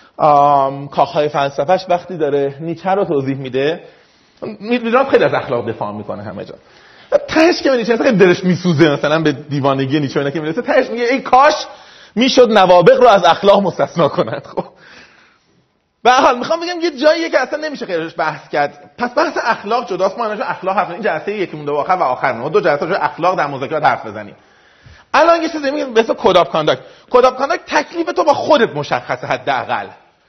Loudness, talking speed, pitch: -14 LUFS, 185 wpm, 200 Hz